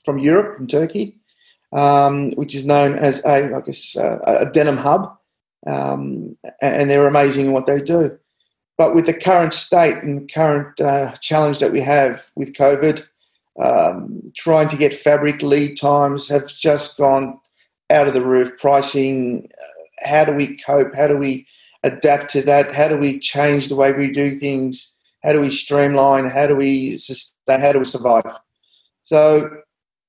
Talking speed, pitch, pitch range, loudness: 170 wpm, 140 Hz, 135-150 Hz, -16 LUFS